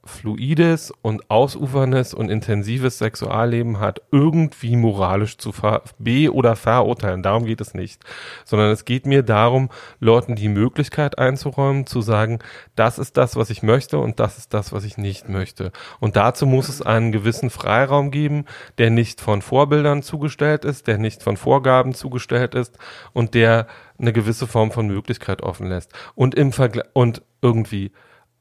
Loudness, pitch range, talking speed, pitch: -19 LUFS, 110-130 Hz, 165 wpm, 120 Hz